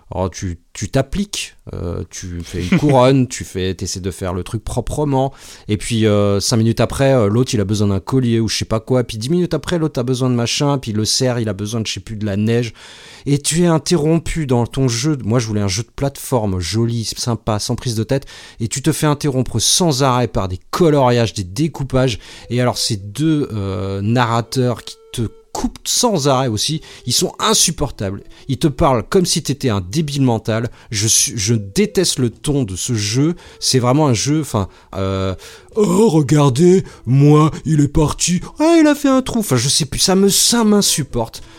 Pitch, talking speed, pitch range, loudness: 125 Hz, 215 wpm, 110-150 Hz, -16 LUFS